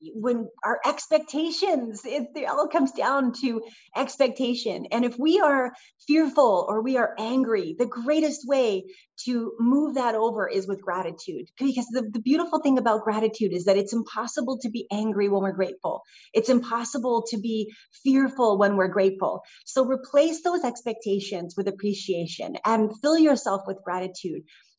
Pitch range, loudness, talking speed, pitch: 215-285 Hz, -25 LUFS, 155 wpm, 240 Hz